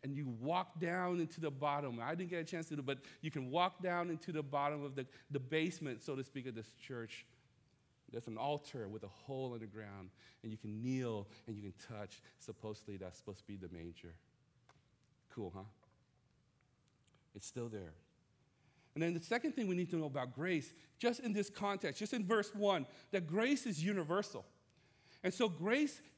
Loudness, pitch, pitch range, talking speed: -41 LUFS, 140 Hz, 115-170 Hz, 200 wpm